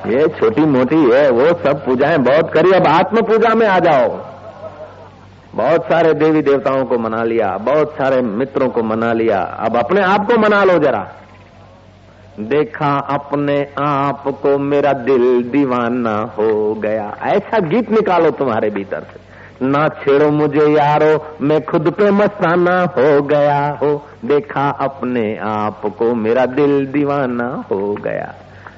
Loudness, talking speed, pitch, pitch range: -15 LUFS, 145 wpm, 140 Hz, 115-155 Hz